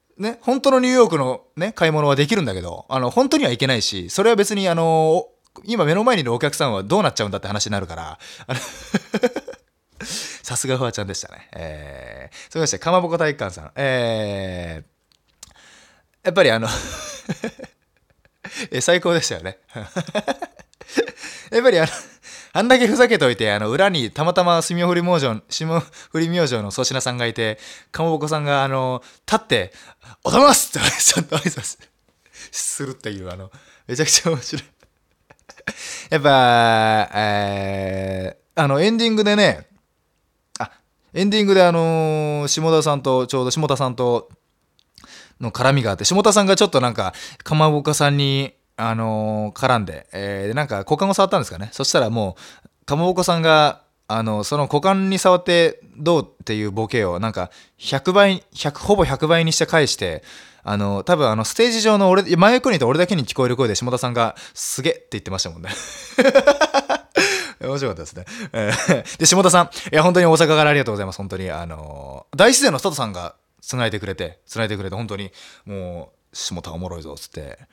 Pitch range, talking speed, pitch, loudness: 105-180 Hz, 355 characters per minute, 140 Hz, -18 LUFS